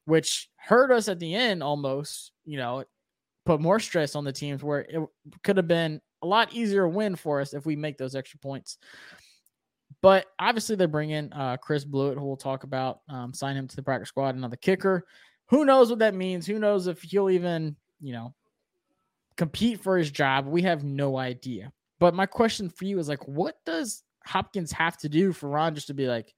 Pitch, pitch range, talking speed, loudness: 160 Hz, 140-190 Hz, 210 wpm, -26 LUFS